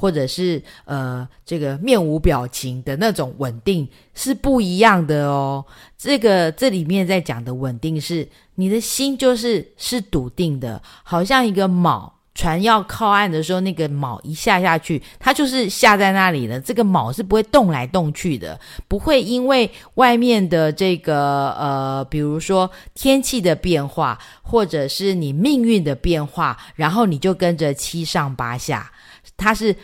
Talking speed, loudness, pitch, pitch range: 235 characters per minute, -18 LUFS, 175 Hz, 145-215 Hz